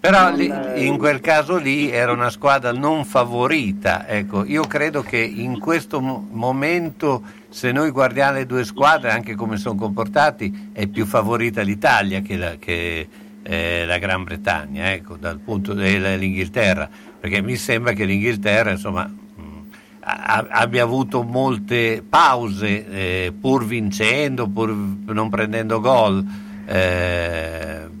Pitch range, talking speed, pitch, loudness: 100-125 Hz, 135 wpm, 105 Hz, -19 LUFS